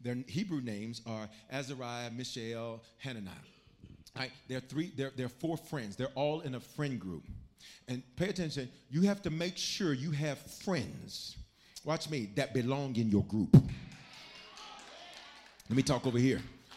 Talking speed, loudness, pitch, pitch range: 155 wpm, -35 LUFS, 130 Hz, 120-150 Hz